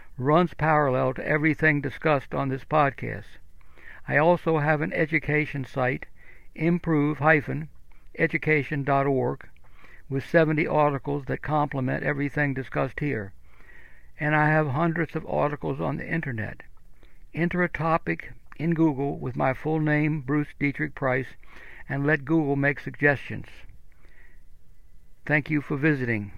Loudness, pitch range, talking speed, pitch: -25 LUFS, 135-155 Hz, 120 wpm, 150 Hz